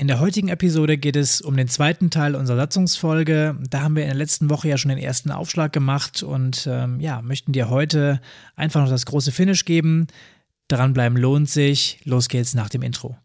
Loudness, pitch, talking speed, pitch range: -20 LUFS, 145 Hz, 210 wpm, 130-155 Hz